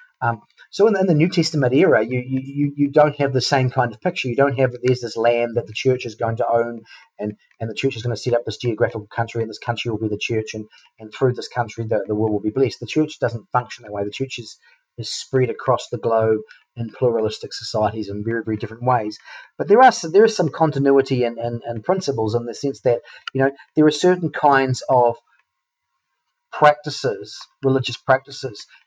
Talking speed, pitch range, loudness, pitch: 230 wpm, 115-140 Hz, -20 LUFS, 125 Hz